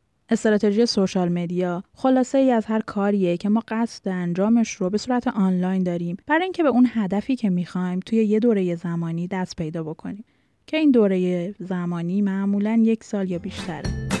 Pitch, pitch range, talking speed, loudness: 200 Hz, 180-225 Hz, 170 wpm, -22 LUFS